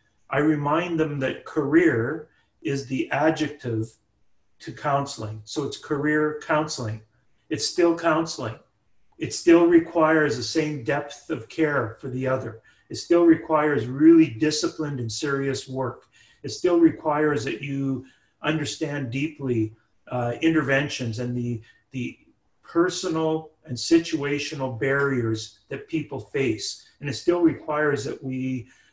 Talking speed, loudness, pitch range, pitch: 125 wpm, -24 LUFS, 125-155 Hz, 145 Hz